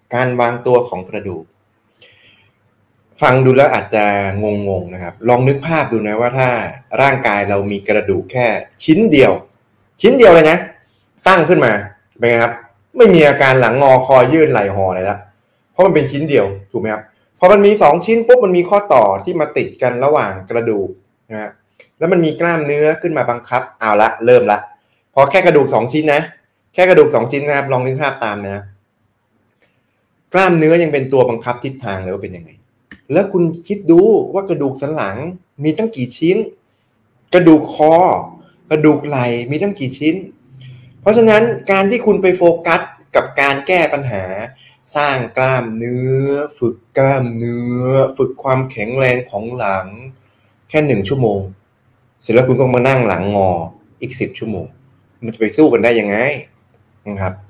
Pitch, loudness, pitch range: 125 Hz, -13 LUFS, 110-155 Hz